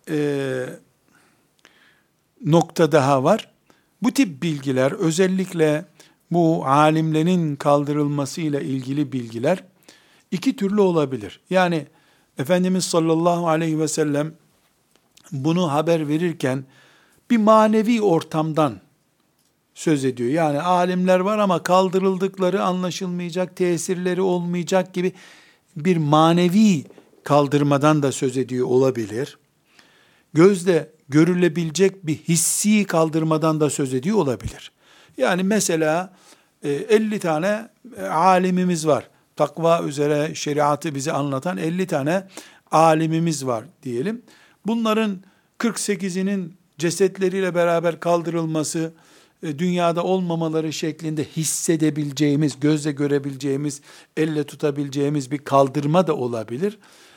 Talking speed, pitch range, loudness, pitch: 90 wpm, 150-185 Hz, -21 LUFS, 160 Hz